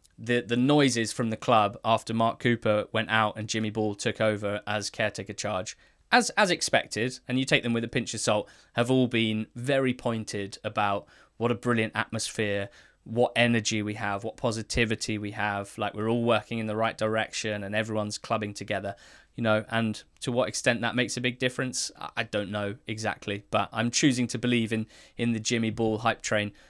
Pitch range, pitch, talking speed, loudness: 105-120 Hz, 110 Hz, 200 wpm, -28 LUFS